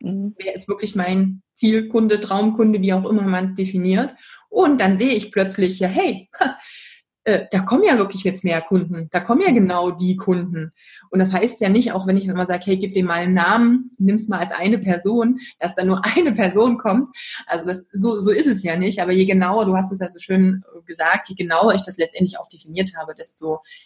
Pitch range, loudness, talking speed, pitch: 180-220 Hz, -19 LUFS, 220 wpm, 190 Hz